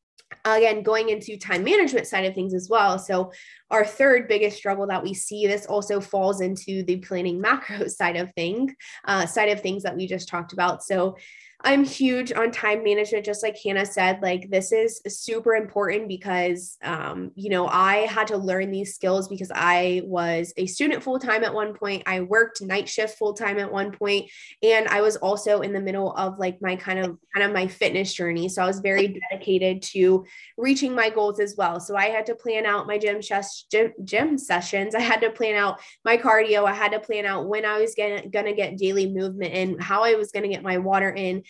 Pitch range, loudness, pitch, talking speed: 185-215 Hz, -23 LUFS, 200 Hz, 215 wpm